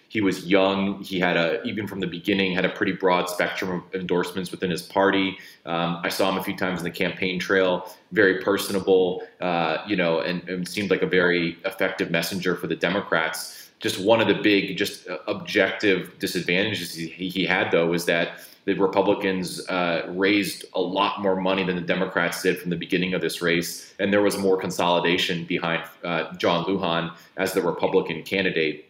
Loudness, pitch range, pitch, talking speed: -24 LUFS, 85-95 Hz, 90 Hz, 190 wpm